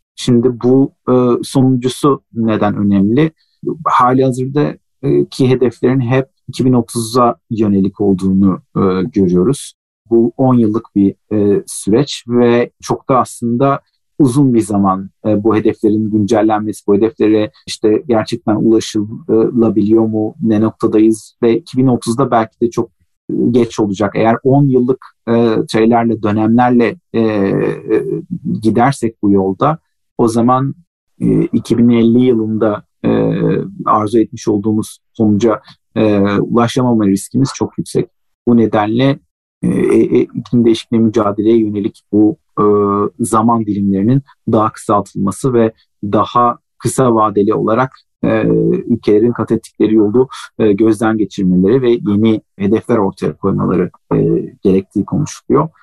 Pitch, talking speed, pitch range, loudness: 110 Hz, 110 wpm, 105-120 Hz, -13 LUFS